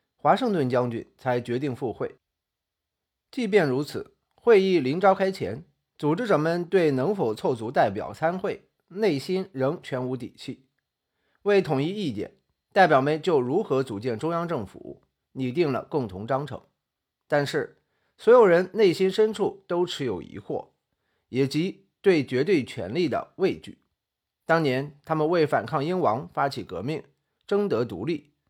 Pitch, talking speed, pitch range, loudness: 150 Hz, 220 characters per minute, 130-190 Hz, -25 LUFS